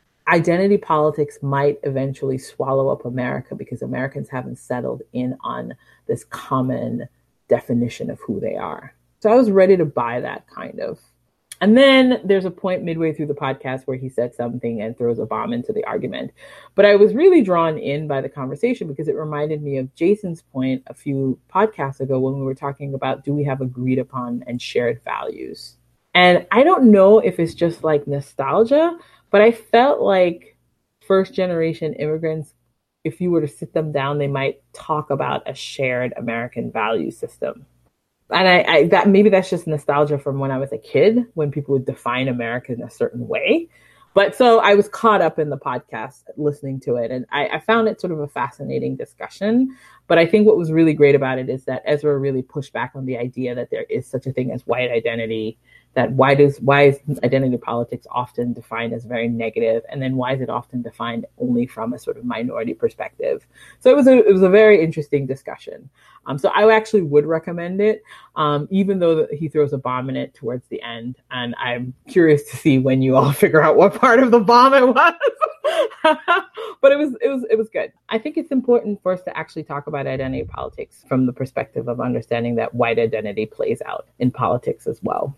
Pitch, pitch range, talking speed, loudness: 145 Hz, 125-195 Hz, 205 wpm, -18 LUFS